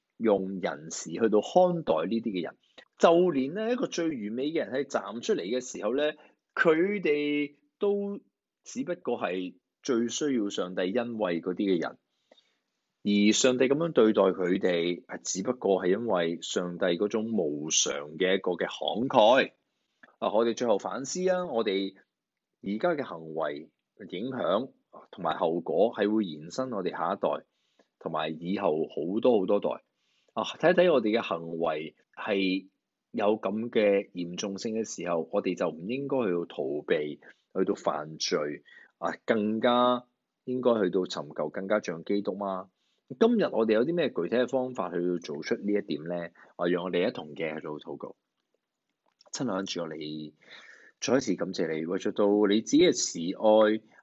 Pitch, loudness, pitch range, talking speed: 105 Hz, -28 LUFS, 90-125 Hz, 235 characters per minute